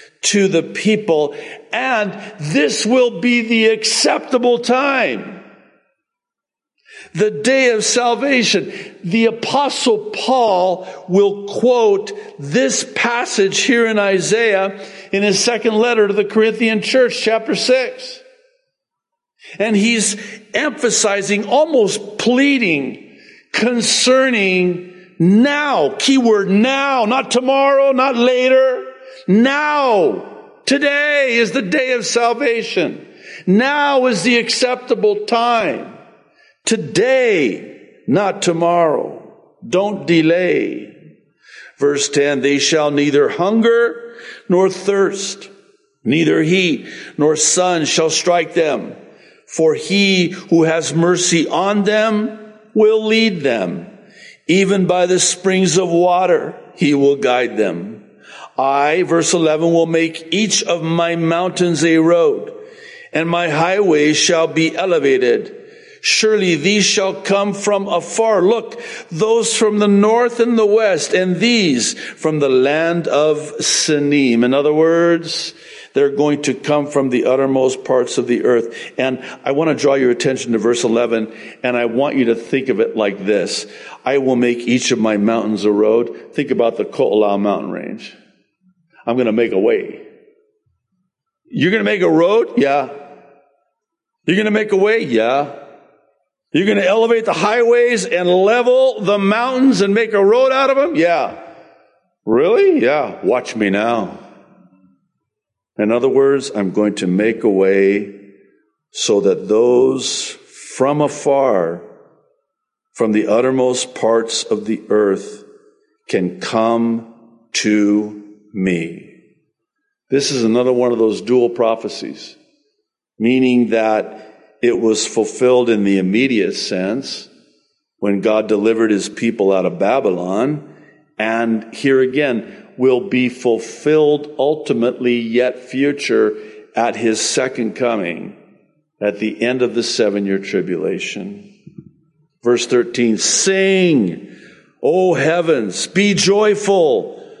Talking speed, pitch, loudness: 125 wpm, 185 Hz, -15 LUFS